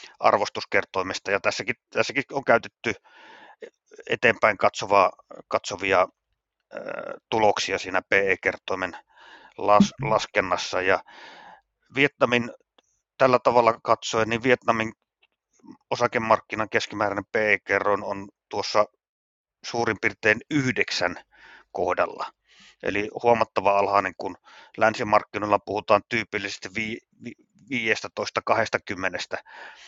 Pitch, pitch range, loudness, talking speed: 110 Hz, 105-125 Hz, -24 LUFS, 80 wpm